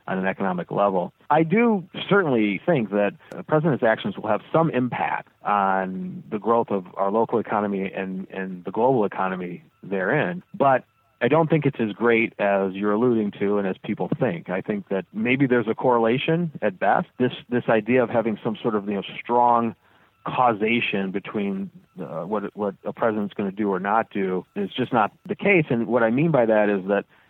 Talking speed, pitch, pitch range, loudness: 200 wpm, 115 Hz, 100-140 Hz, -23 LUFS